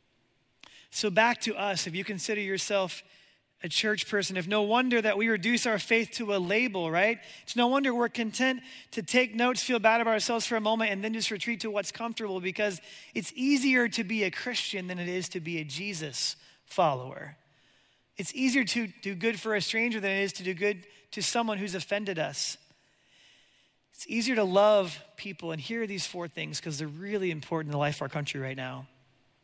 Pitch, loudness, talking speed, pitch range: 205 Hz, -29 LUFS, 205 wpm, 175-230 Hz